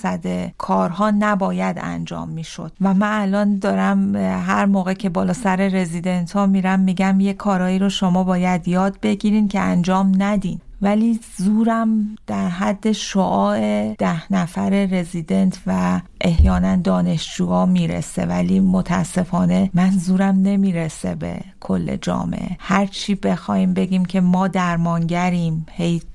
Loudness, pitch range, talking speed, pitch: -19 LUFS, 160-195 Hz, 125 wpm, 185 Hz